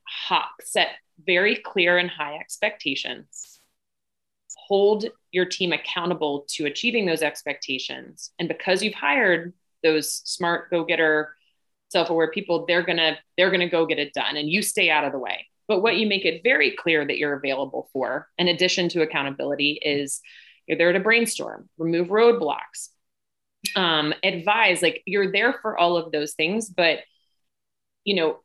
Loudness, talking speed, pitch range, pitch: -22 LUFS, 160 wpm, 150-190 Hz, 170 Hz